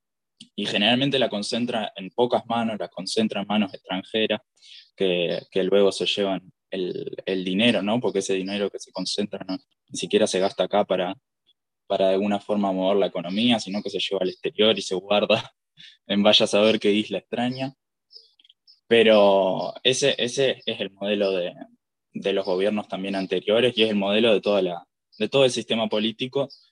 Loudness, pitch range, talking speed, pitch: -23 LUFS, 95-115 Hz, 180 wpm, 105 Hz